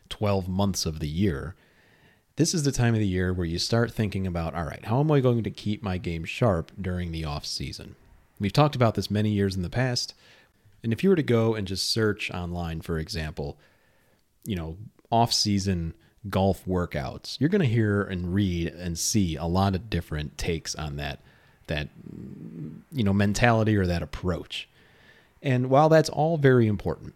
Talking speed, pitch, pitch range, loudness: 190 wpm, 100 Hz, 85-115 Hz, -26 LUFS